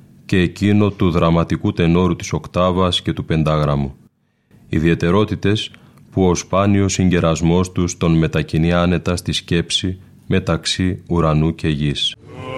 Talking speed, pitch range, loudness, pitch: 120 wpm, 80-100 Hz, -17 LUFS, 90 Hz